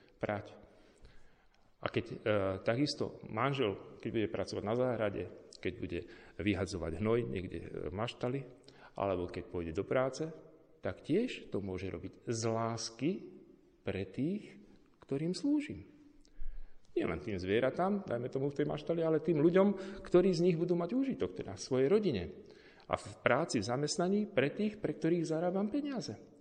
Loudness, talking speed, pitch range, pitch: -35 LUFS, 150 wpm, 105-175 Hz, 135 Hz